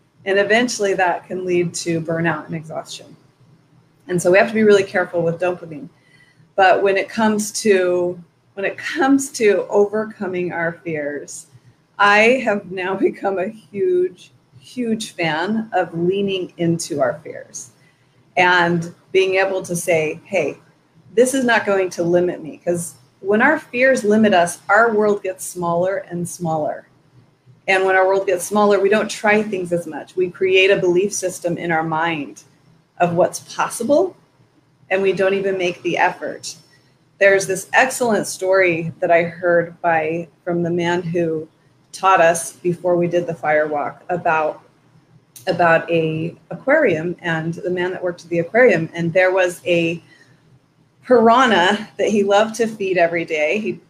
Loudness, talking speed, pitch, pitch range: -18 LUFS, 160 wpm, 175 Hz, 165-195 Hz